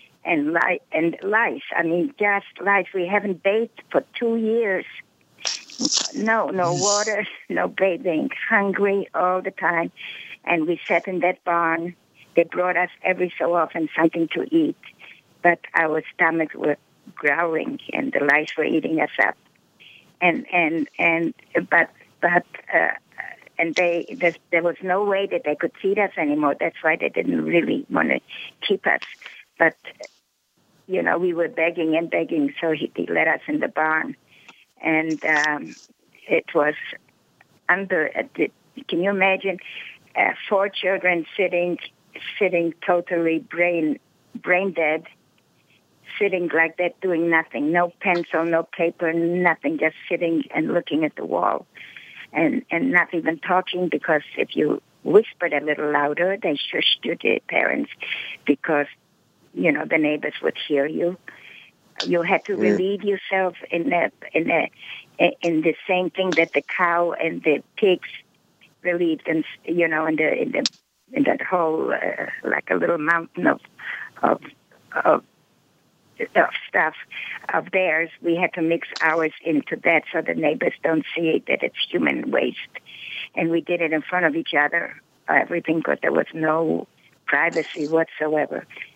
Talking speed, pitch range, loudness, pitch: 155 wpm, 160-190 Hz, -22 LUFS, 170 Hz